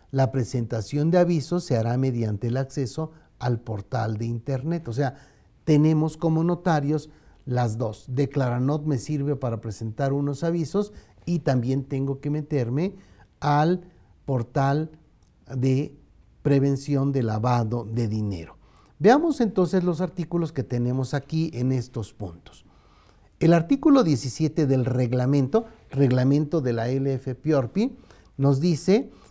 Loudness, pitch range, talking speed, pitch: -24 LUFS, 125-160 Hz, 125 wpm, 140 Hz